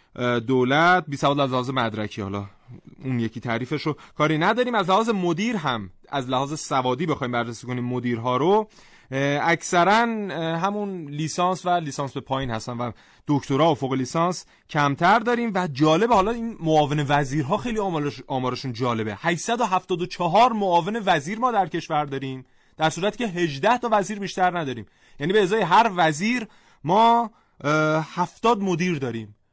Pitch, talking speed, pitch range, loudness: 155 Hz, 150 wpm, 130-190 Hz, -23 LUFS